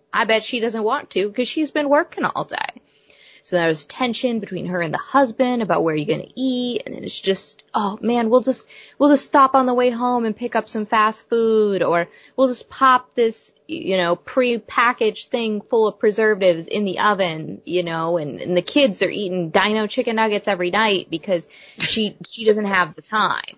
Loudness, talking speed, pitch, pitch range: -20 LUFS, 210 wpm, 220 Hz, 185-245 Hz